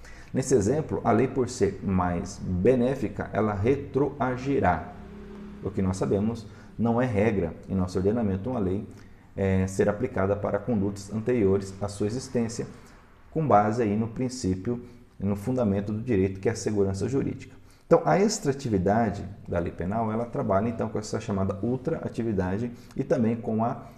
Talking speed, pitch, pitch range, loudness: 155 wpm, 105 Hz, 100-120 Hz, -27 LUFS